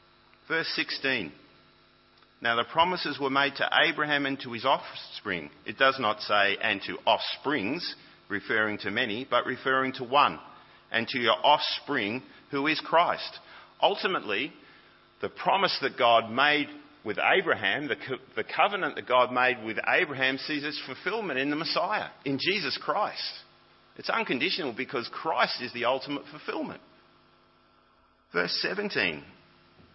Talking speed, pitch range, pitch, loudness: 140 wpm, 105-145 Hz, 130 Hz, -27 LUFS